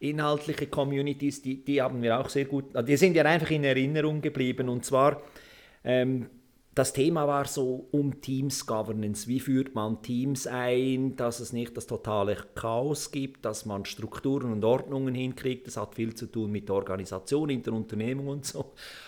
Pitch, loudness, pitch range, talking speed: 130 Hz, -29 LUFS, 115-140 Hz, 175 wpm